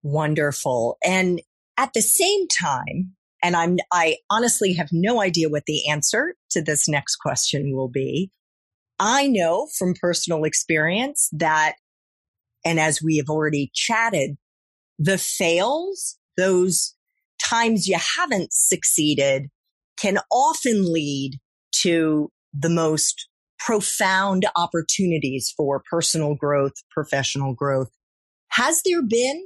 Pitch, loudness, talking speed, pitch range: 170 Hz, -21 LUFS, 115 wpm, 150-205 Hz